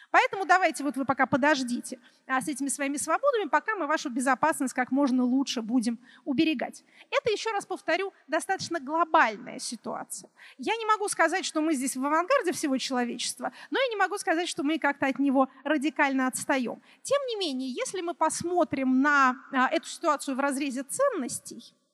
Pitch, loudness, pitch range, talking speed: 290 Hz, -27 LUFS, 265-335 Hz, 165 wpm